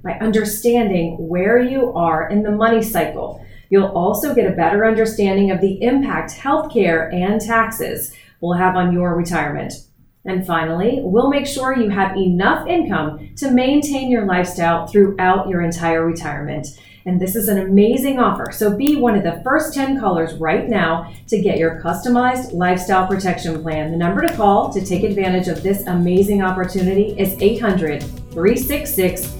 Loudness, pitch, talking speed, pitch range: -17 LUFS, 195 Hz, 165 wpm, 175-225 Hz